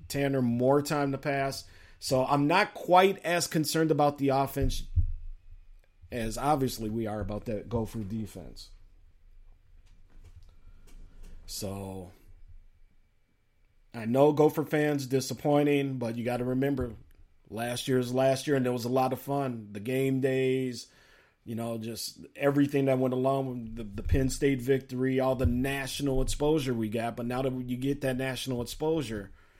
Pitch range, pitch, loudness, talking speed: 95-135 Hz, 125 Hz, -29 LUFS, 150 wpm